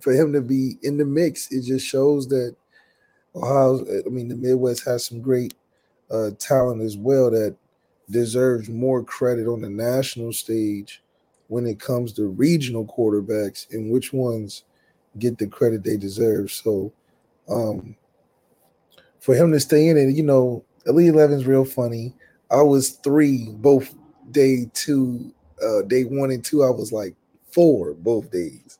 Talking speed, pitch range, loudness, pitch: 160 wpm, 115-135 Hz, -21 LUFS, 125 Hz